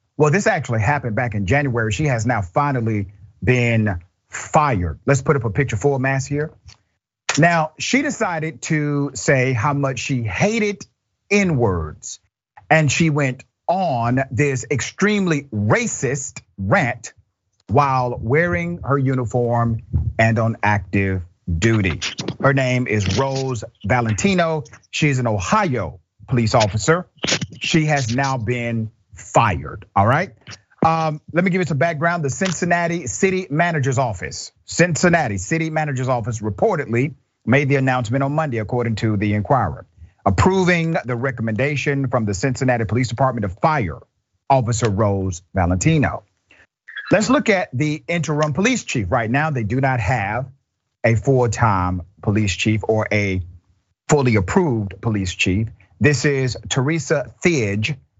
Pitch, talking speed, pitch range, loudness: 125 Hz, 135 wpm, 110-150 Hz, -19 LUFS